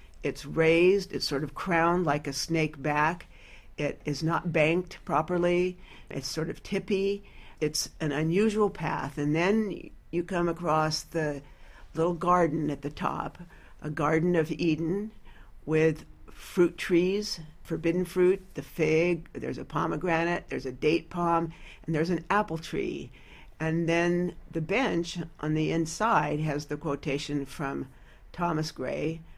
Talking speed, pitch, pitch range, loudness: 145 wpm, 160 Hz, 150-175 Hz, -28 LUFS